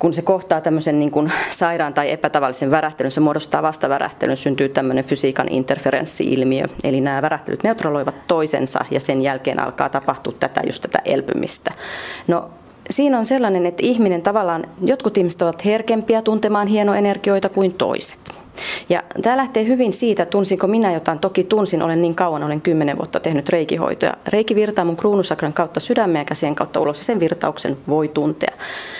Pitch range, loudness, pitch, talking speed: 150-205 Hz, -19 LUFS, 170 Hz, 160 wpm